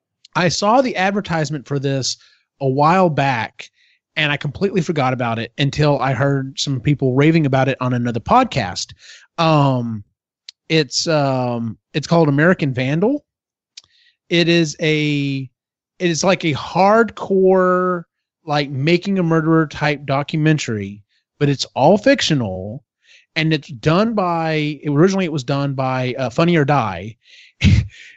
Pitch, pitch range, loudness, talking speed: 150 Hz, 135-170 Hz, -17 LUFS, 135 wpm